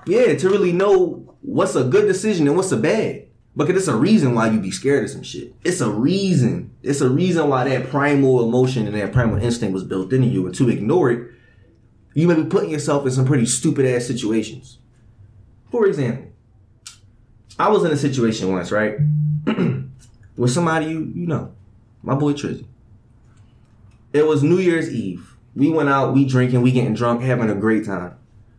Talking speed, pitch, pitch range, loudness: 190 wpm, 125 Hz, 110-145 Hz, -19 LUFS